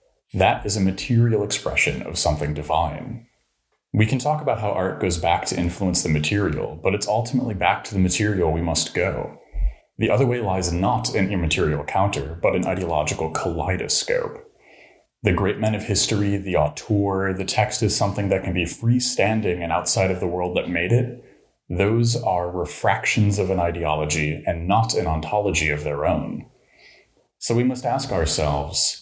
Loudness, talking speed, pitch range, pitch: -22 LUFS, 170 wpm, 85-110 Hz, 100 Hz